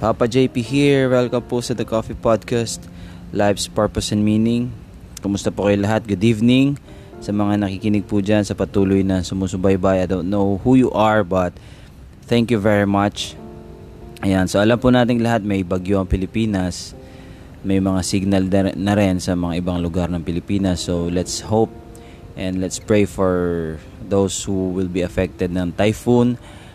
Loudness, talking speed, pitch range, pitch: -19 LUFS, 165 wpm, 95-110 Hz, 100 Hz